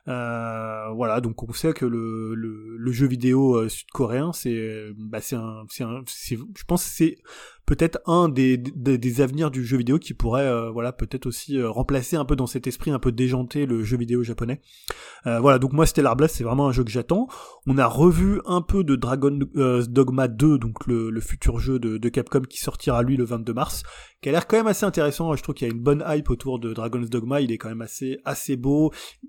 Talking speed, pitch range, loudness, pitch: 230 wpm, 120-145 Hz, -23 LUFS, 130 Hz